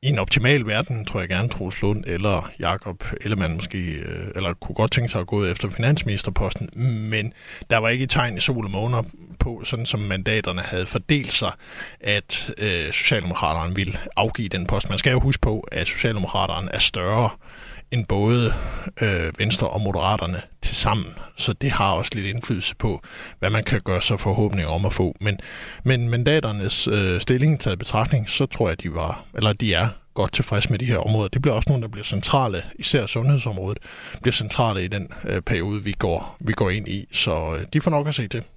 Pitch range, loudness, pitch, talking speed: 95-120 Hz, -22 LUFS, 105 Hz, 200 wpm